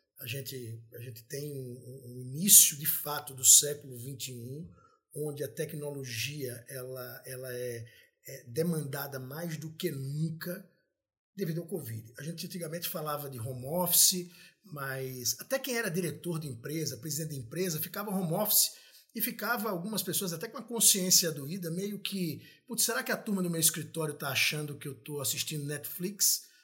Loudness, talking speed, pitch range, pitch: -29 LUFS, 165 wpm, 135-185 Hz, 155 Hz